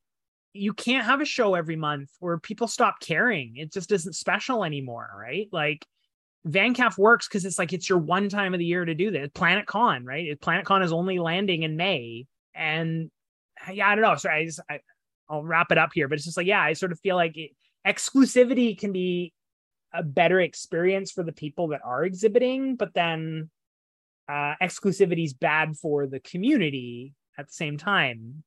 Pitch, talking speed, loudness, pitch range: 175 Hz, 195 wpm, -25 LUFS, 155-200 Hz